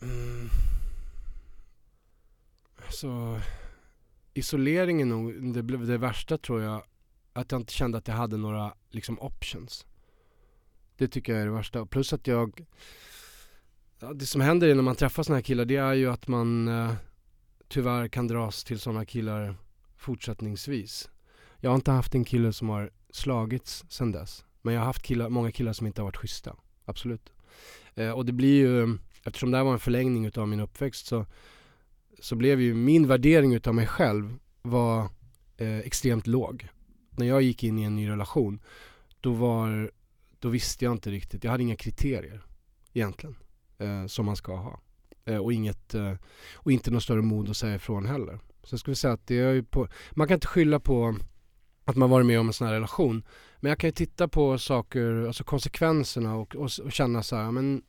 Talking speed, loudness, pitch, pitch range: 185 wpm, -28 LUFS, 120 Hz, 110-130 Hz